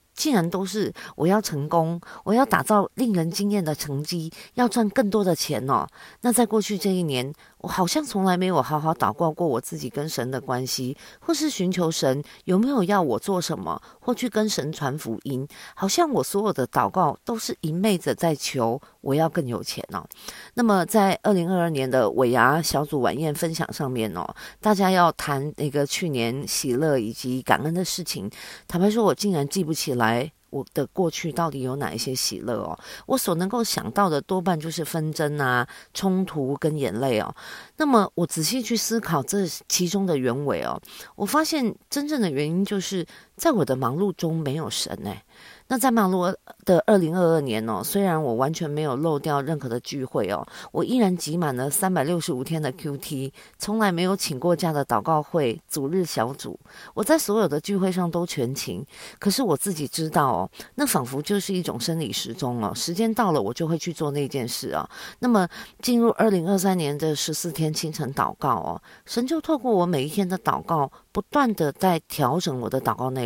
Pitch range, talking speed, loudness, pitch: 140-200 Hz, 285 characters per minute, -24 LUFS, 170 Hz